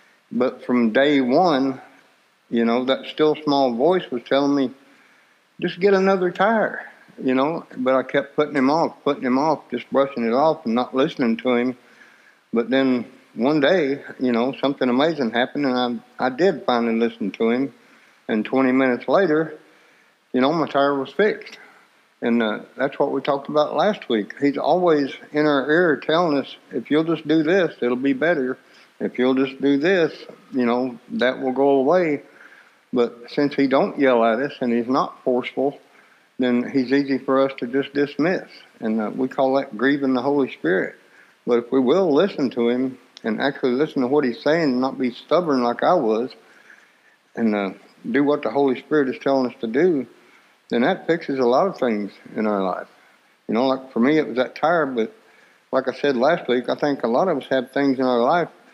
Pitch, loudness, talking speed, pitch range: 130 Hz, -21 LUFS, 200 wpm, 125-145 Hz